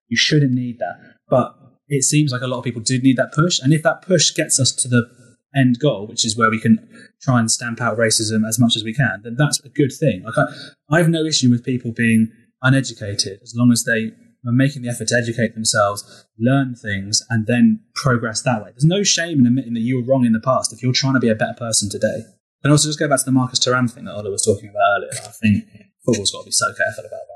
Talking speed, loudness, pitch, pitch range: 265 wpm, -18 LUFS, 125 Hz, 115-135 Hz